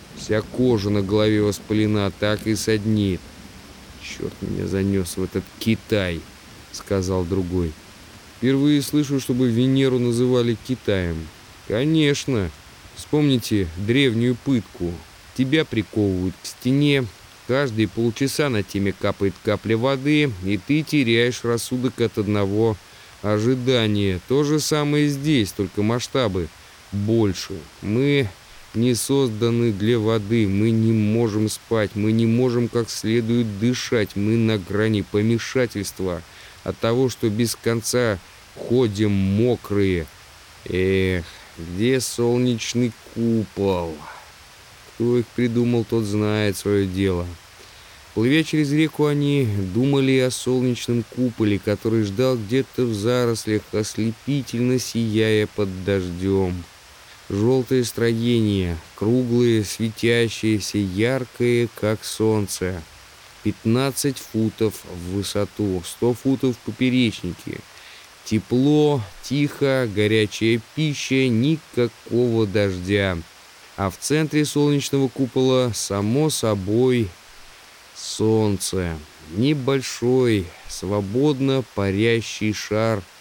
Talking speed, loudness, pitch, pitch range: 100 wpm, -21 LUFS, 110 Hz, 100-125 Hz